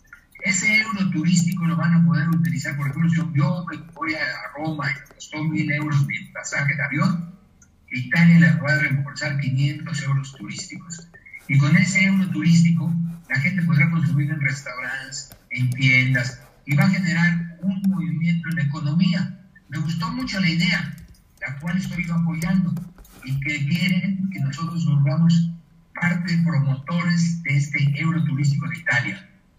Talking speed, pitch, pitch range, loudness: 160 wpm, 165 Hz, 145-175 Hz, -21 LUFS